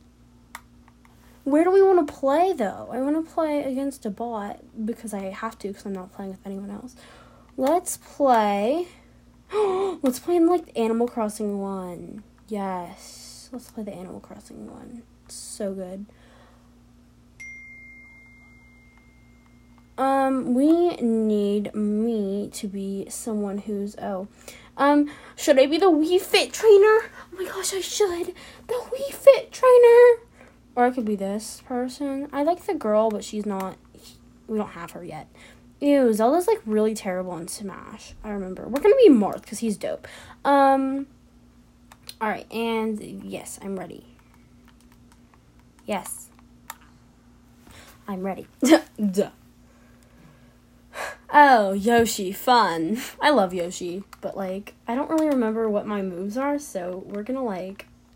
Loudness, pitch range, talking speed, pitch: -22 LUFS, 190-280 Hz, 140 wpm, 220 Hz